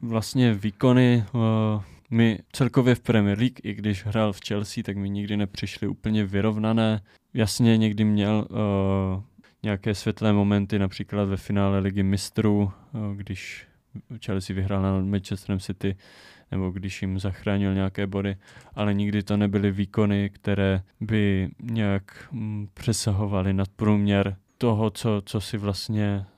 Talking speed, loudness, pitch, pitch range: 140 wpm, -25 LUFS, 105 Hz, 100-110 Hz